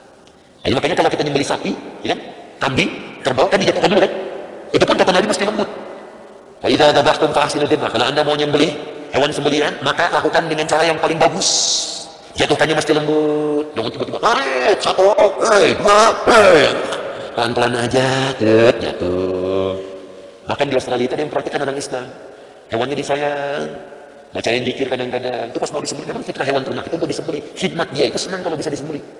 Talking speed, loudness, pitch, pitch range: 175 wpm, -17 LUFS, 150 Hz, 125-155 Hz